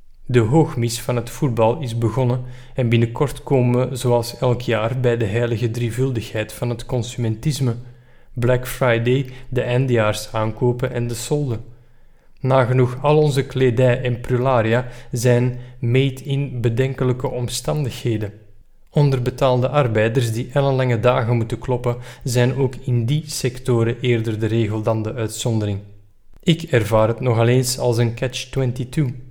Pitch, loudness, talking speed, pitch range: 125 Hz, -20 LUFS, 135 wpm, 115-130 Hz